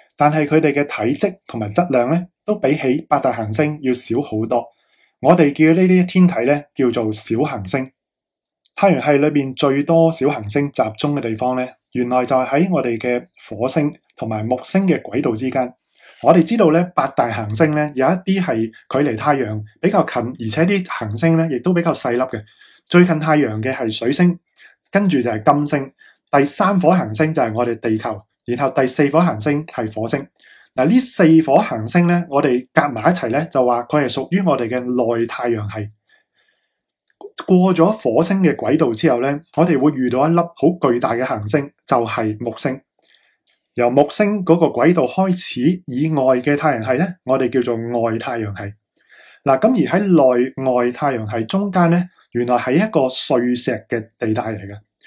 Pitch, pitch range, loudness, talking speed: 140 Hz, 120-165 Hz, -17 LUFS, 265 characters per minute